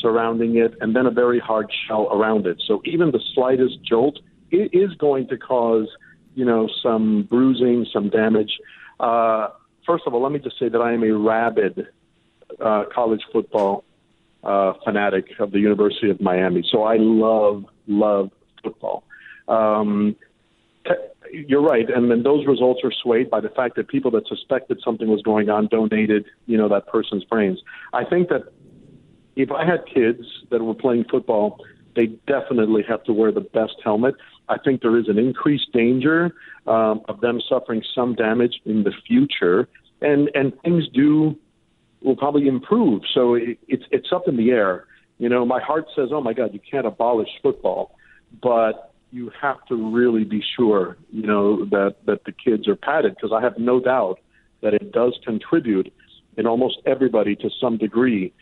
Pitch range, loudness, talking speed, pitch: 110-130 Hz, -20 LUFS, 175 wpm, 115 Hz